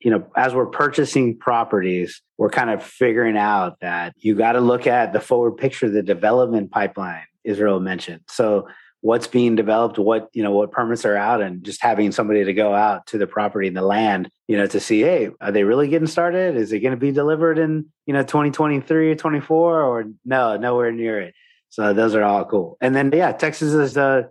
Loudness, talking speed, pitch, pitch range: -19 LUFS, 215 wpm, 115 Hz, 105-145 Hz